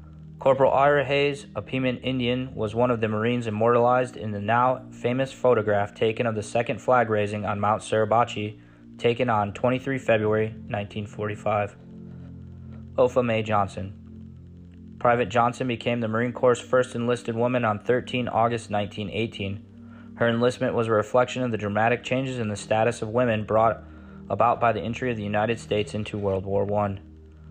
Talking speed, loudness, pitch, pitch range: 155 wpm, -24 LUFS, 115 Hz, 105-125 Hz